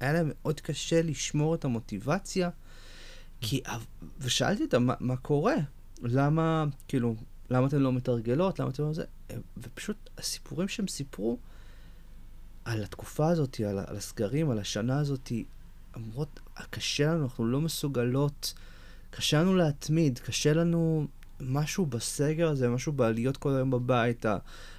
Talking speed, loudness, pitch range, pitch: 130 wpm, -30 LUFS, 115-150 Hz, 130 Hz